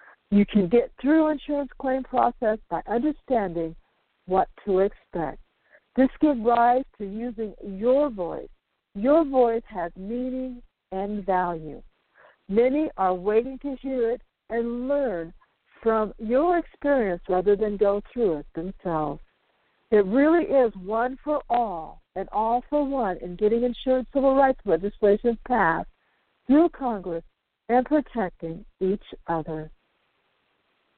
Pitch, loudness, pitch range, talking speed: 230 Hz, -25 LUFS, 195-260 Hz, 125 wpm